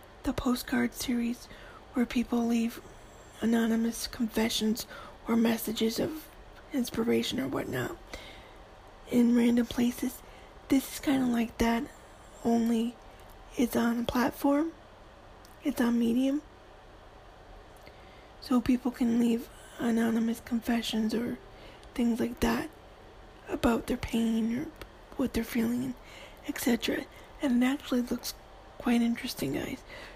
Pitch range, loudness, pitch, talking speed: 230-255 Hz, -30 LUFS, 240 Hz, 110 wpm